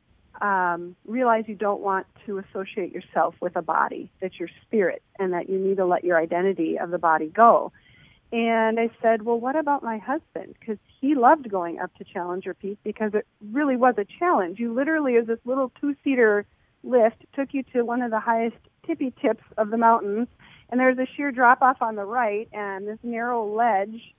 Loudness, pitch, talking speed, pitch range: -24 LUFS, 220 Hz, 200 wpm, 195-245 Hz